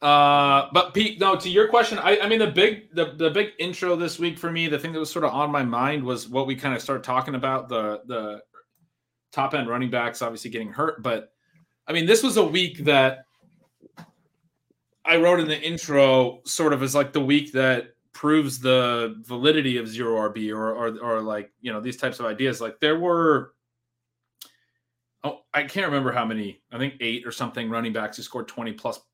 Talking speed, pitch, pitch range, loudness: 210 wpm, 140 Hz, 120-165 Hz, -23 LUFS